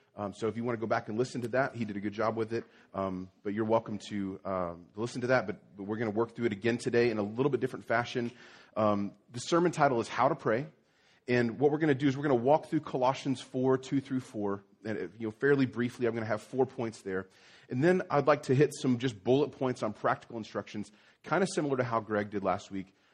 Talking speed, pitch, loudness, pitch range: 265 wpm, 115 Hz, -31 LUFS, 105-130 Hz